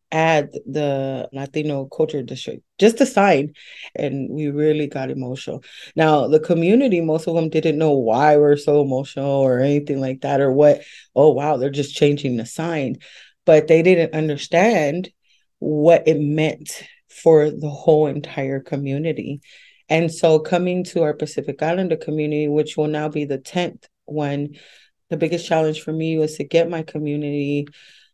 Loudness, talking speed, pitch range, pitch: -19 LUFS, 160 wpm, 145-160 Hz, 150 Hz